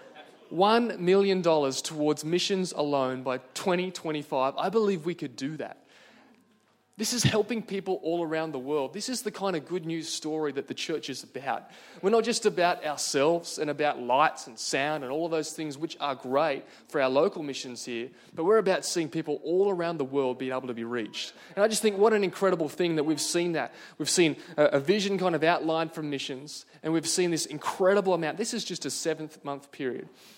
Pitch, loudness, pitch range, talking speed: 160 Hz, -28 LUFS, 145-185 Hz, 205 wpm